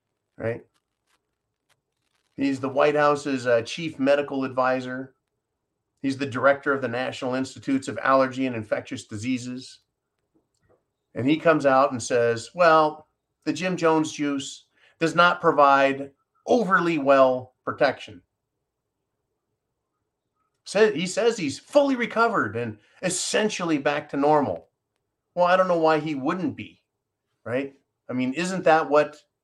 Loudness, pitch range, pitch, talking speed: -23 LUFS, 130-160 Hz, 140 Hz, 130 wpm